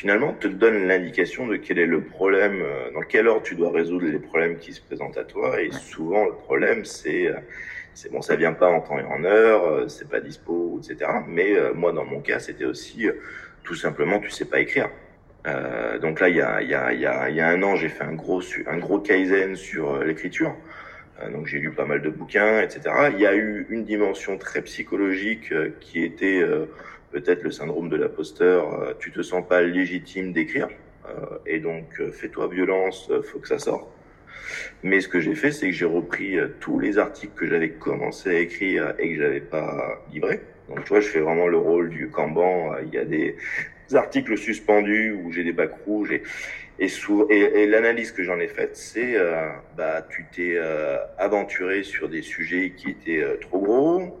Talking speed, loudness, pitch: 210 wpm, -23 LUFS, 375 Hz